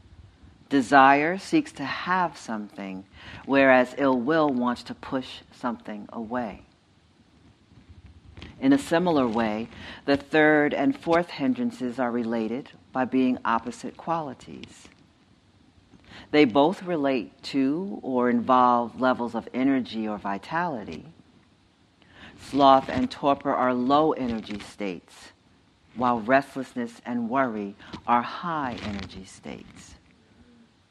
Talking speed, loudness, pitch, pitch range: 105 wpm, -24 LUFS, 125 Hz, 105-140 Hz